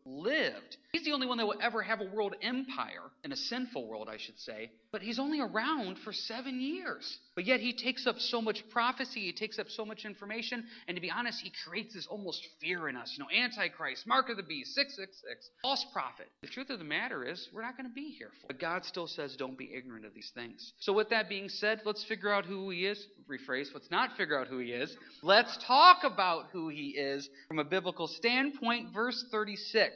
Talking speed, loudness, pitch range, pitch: 235 wpm, -33 LUFS, 180-250 Hz, 215 Hz